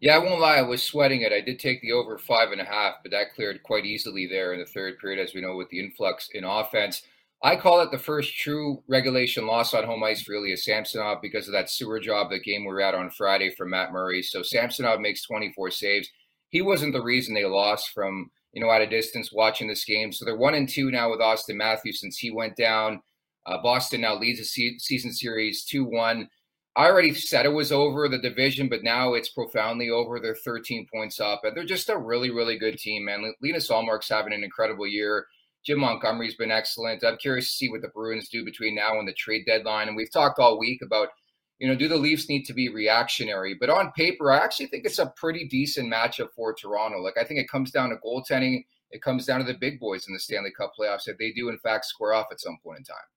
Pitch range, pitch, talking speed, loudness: 110-130 Hz, 115 Hz, 245 wpm, -25 LUFS